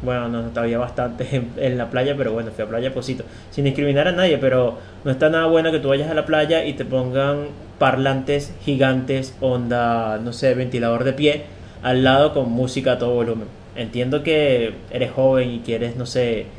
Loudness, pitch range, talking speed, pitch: -20 LUFS, 115-140 Hz, 205 wpm, 125 Hz